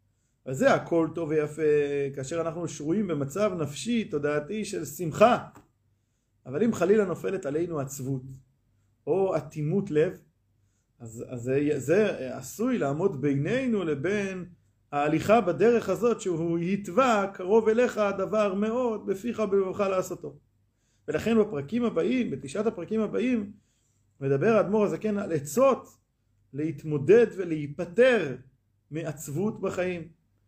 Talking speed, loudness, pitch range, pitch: 110 wpm, -27 LUFS, 135-205 Hz, 160 Hz